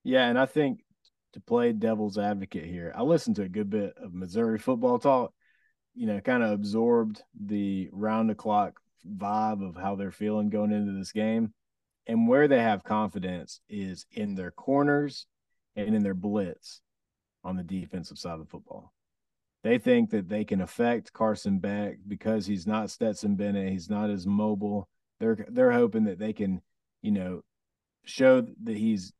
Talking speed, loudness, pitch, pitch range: 175 wpm, -28 LUFS, 105 Hz, 100-125 Hz